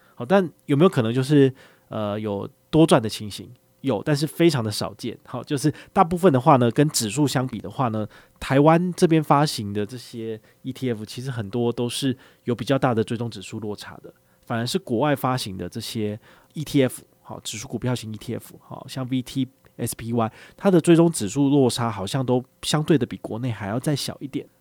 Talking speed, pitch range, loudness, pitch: 300 characters per minute, 115-145 Hz, -23 LUFS, 125 Hz